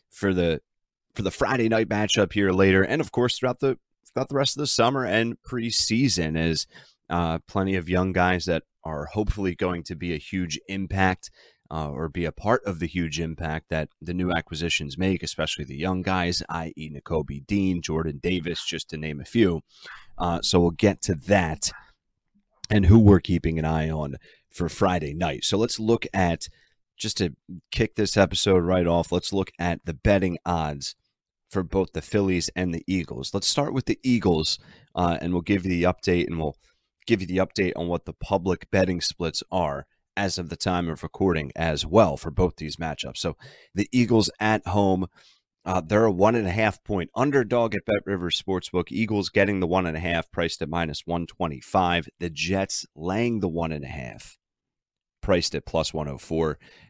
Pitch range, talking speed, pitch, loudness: 80-100 Hz, 190 wpm, 90 Hz, -25 LUFS